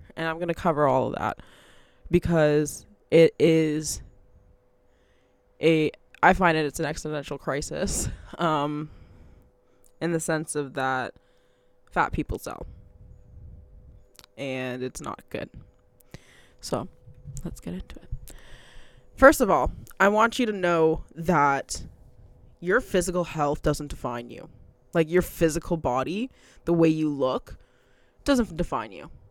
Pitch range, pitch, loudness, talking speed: 100-165 Hz, 145 Hz, -25 LUFS, 130 wpm